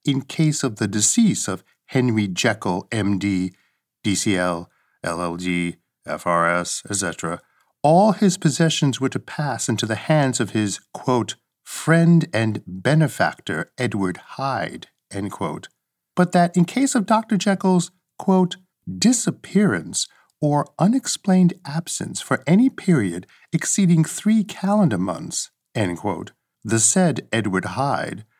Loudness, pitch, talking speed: -21 LUFS, 145 Hz, 120 wpm